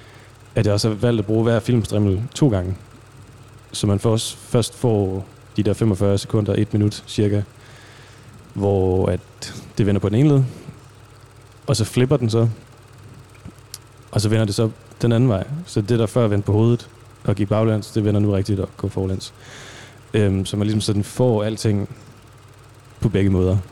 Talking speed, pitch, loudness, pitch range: 180 wpm, 110 Hz, -20 LUFS, 105-120 Hz